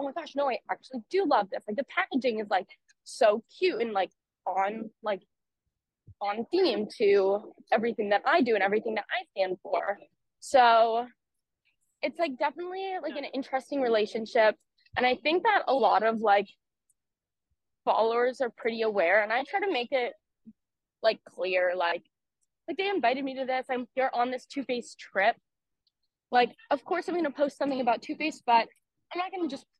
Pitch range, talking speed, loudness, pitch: 220-295 Hz, 180 wpm, -28 LUFS, 250 Hz